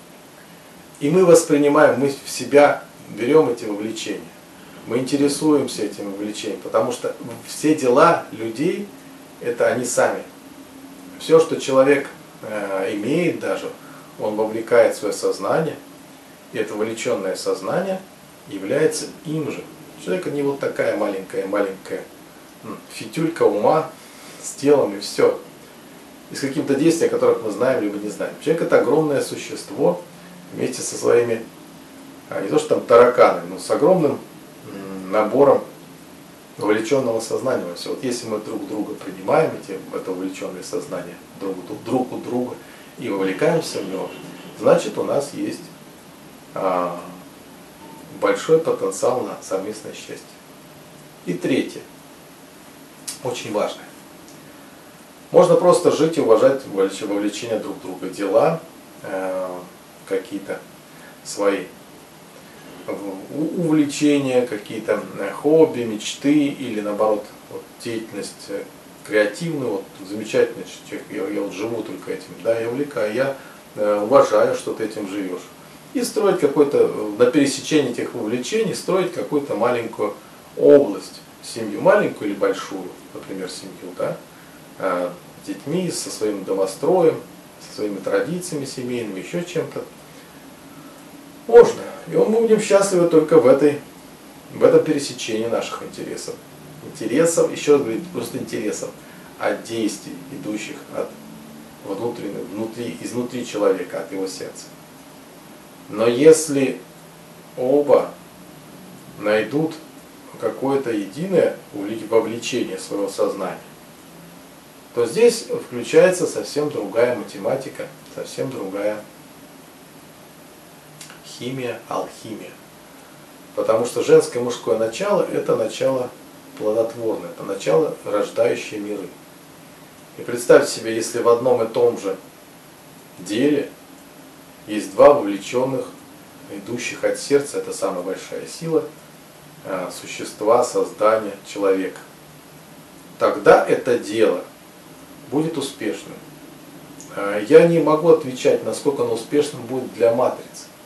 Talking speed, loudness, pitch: 110 wpm, -20 LUFS, 150 Hz